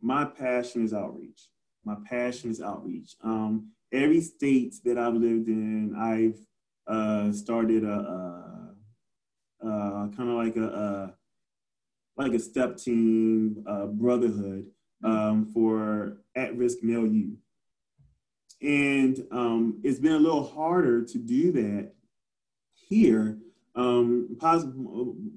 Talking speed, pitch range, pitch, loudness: 120 wpm, 110-125 Hz, 115 Hz, -27 LUFS